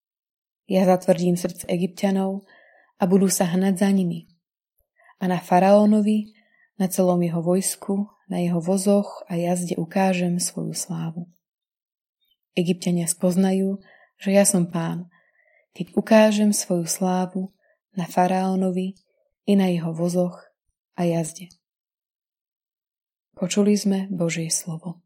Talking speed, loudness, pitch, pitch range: 115 wpm, -22 LUFS, 185 Hz, 175-200 Hz